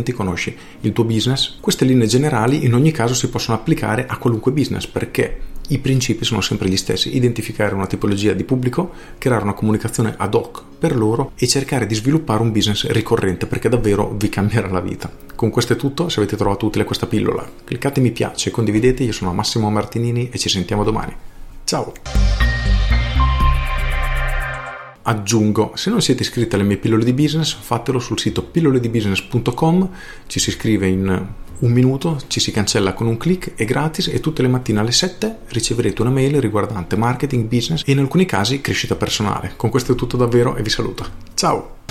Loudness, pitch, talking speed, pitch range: -18 LUFS, 115 Hz, 180 wpm, 105-130 Hz